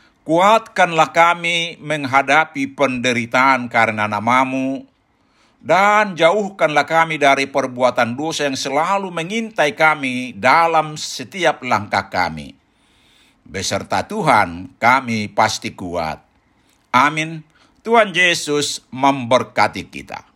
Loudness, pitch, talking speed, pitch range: -16 LUFS, 140 Hz, 90 wpm, 125-165 Hz